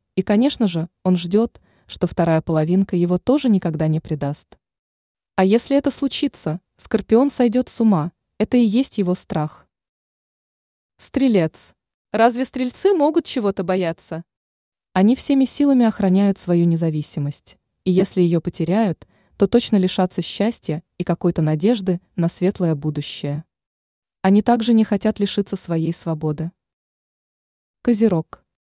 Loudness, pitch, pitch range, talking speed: -20 LUFS, 185 Hz, 165-225 Hz, 125 wpm